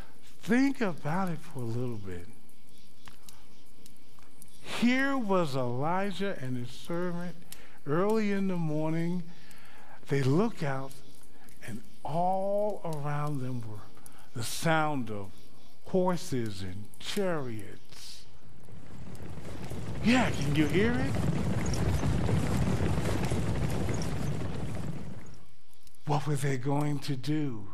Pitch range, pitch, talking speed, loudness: 130-185 Hz, 150 Hz, 90 wpm, -31 LUFS